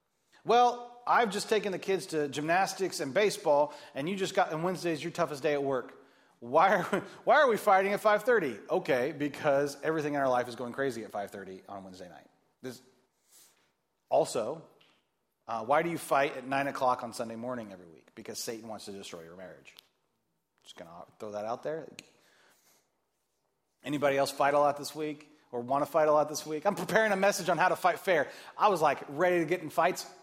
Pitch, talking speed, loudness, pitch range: 150 Hz, 210 wpm, -29 LUFS, 135-185 Hz